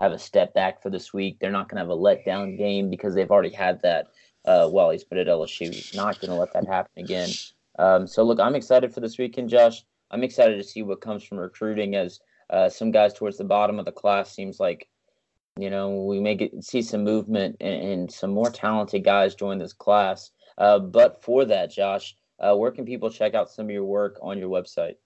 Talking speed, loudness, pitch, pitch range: 230 wpm, -23 LUFS, 105 Hz, 100-110 Hz